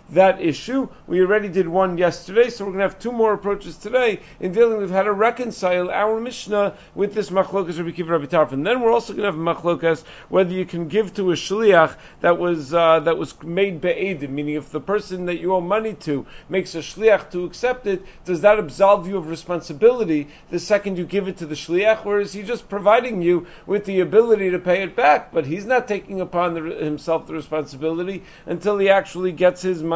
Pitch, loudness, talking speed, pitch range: 185 Hz, -20 LUFS, 220 wpm, 170-205 Hz